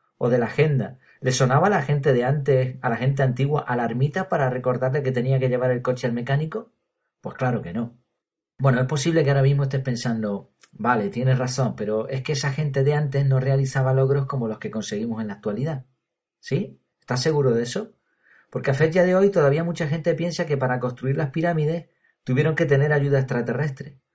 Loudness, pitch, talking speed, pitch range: -23 LUFS, 135 Hz, 205 wpm, 125-150 Hz